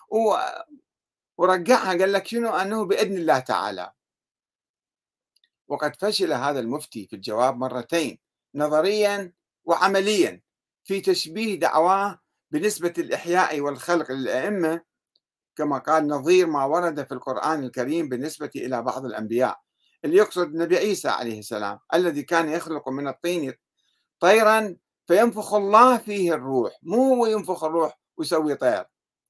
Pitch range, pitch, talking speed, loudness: 155-210 Hz, 180 Hz, 115 wpm, -23 LUFS